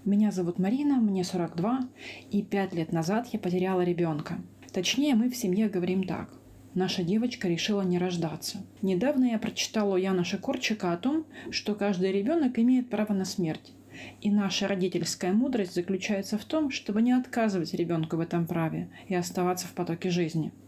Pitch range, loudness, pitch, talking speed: 180-220 Hz, -29 LUFS, 195 Hz, 165 wpm